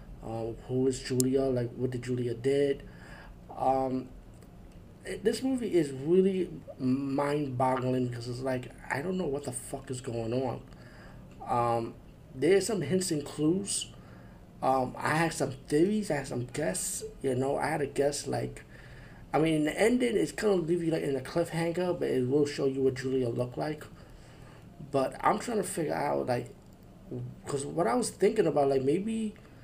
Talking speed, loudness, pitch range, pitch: 175 wpm, -30 LUFS, 125-165 Hz, 135 Hz